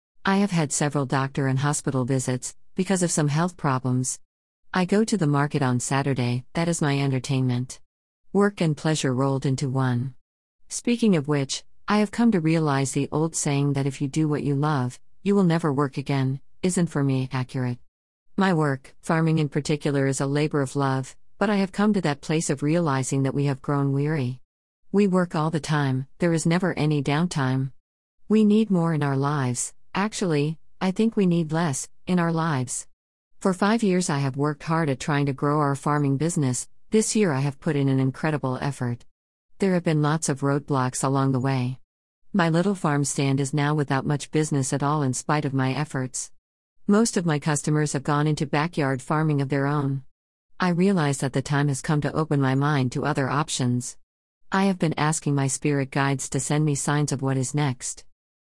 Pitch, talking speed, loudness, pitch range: 145 Hz, 200 wpm, -24 LUFS, 135-160 Hz